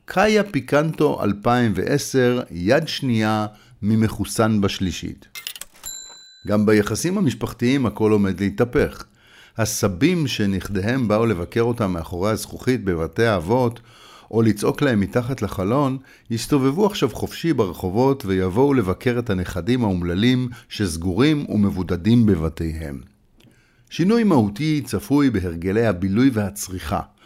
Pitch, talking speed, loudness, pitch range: 110 Hz, 100 wpm, -20 LUFS, 100-125 Hz